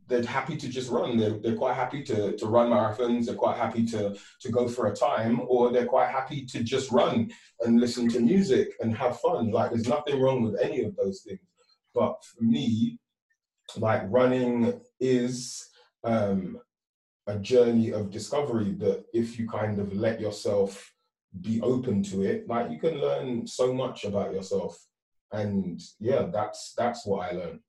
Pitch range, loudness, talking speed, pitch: 110-130 Hz, -27 LUFS, 180 wpm, 120 Hz